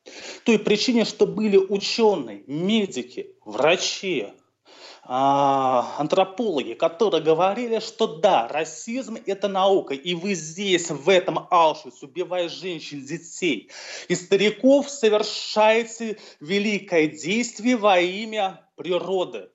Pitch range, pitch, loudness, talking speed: 170-225 Hz, 195 Hz, -22 LUFS, 100 wpm